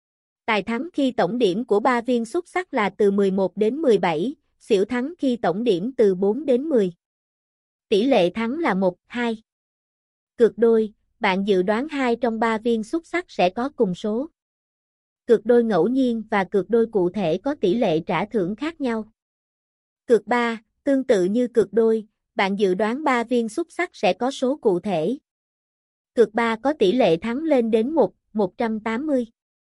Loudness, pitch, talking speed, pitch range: -22 LUFS, 230 Hz, 180 wpm, 205-250 Hz